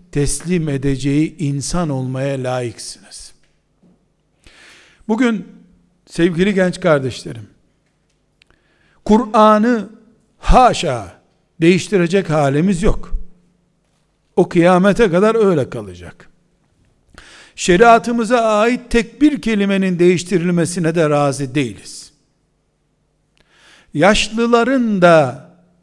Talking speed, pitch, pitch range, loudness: 70 wpm, 180 Hz, 145-215 Hz, -15 LUFS